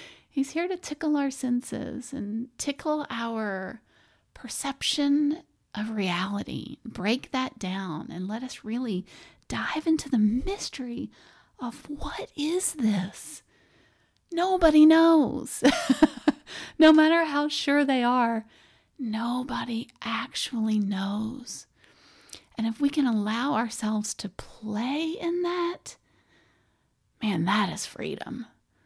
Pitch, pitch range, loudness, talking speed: 255 Hz, 220-295 Hz, -27 LUFS, 110 wpm